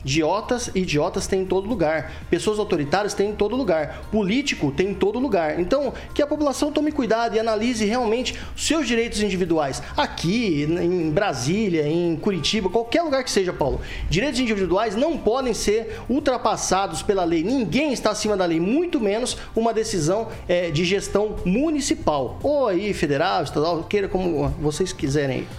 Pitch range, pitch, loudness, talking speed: 180-240 Hz, 205 Hz, -22 LUFS, 165 wpm